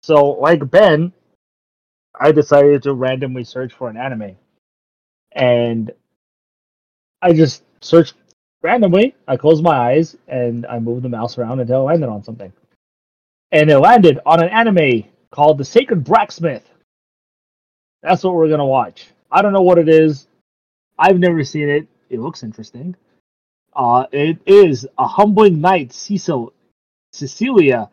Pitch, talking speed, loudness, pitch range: 140 Hz, 145 wpm, -14 LUFS, 120-170 Hz